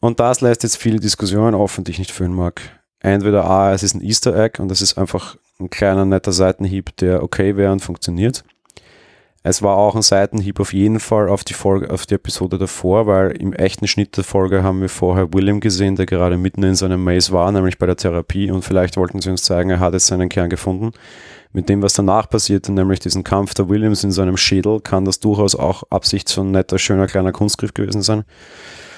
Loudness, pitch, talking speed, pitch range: -16 LUFS, 95 Hz, 225 wpm, 95-100 Hz